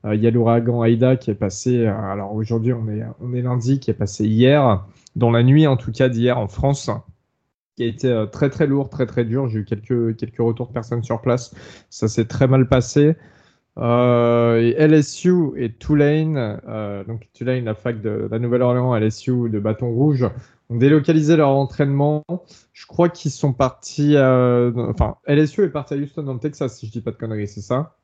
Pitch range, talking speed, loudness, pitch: 115-140 Hz, 210 wpm, -19 LUFS, 125 Hz